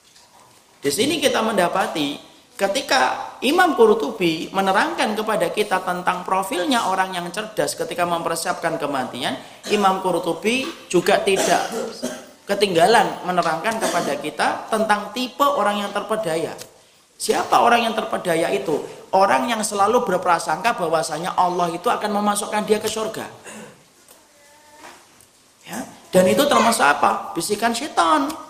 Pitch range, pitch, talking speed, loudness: 180-245 Hz, 210 Hz, 115 wpm, -20 LUFS